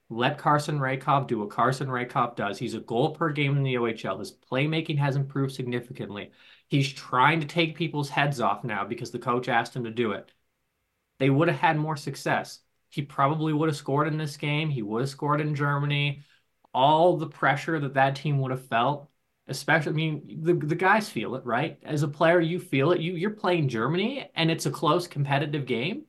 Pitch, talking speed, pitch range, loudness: 145 Hz, 210 wpm, 130-160 Hz, -26 LUFS